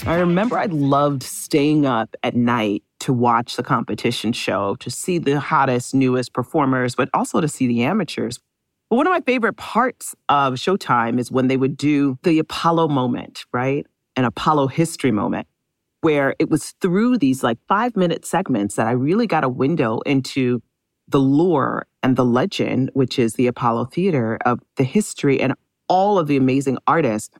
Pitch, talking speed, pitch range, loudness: 135 Hz, 175 wpm, 125-160 Hz, -19 LUFS